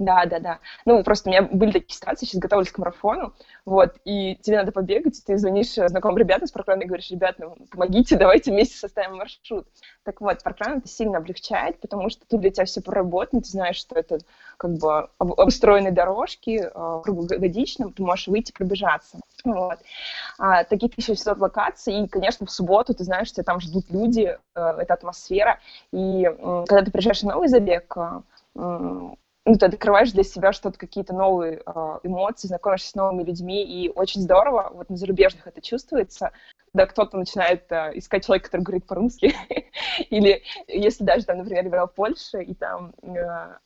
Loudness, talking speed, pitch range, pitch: -22 LUFS, 175 wpm, 180-210 Hz, 195 Hz